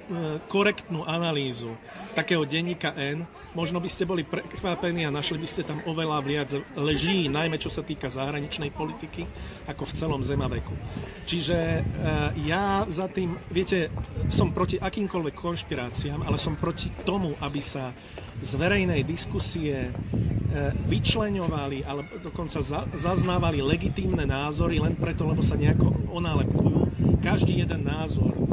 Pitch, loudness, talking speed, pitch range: 160 Hz, -27 LUFS, 130 wpm, 145-175 Hz